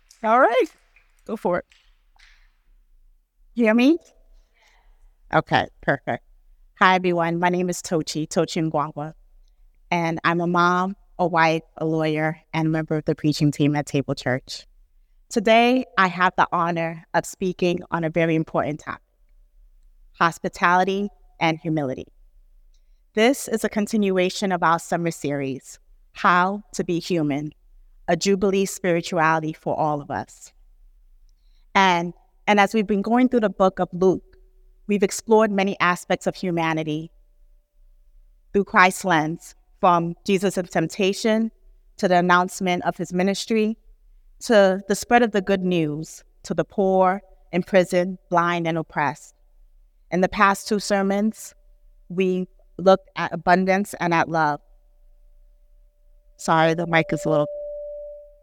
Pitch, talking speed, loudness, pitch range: 175 Hz, 135 wpm, -21 LUFS, 160-195 Hz